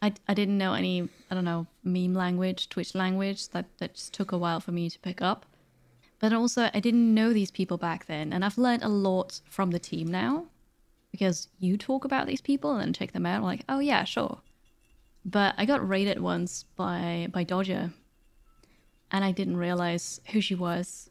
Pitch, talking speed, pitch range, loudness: 185 Hz, 205 wpm, 175-210 Hz, -29 LUFS